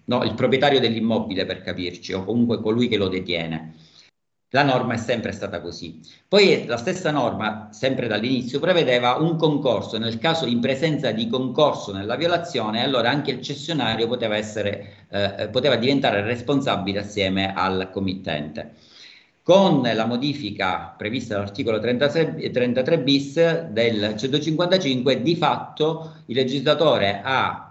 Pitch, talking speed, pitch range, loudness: 120 Hz, 135 wpm, 100-140 Hz, -22 LUFS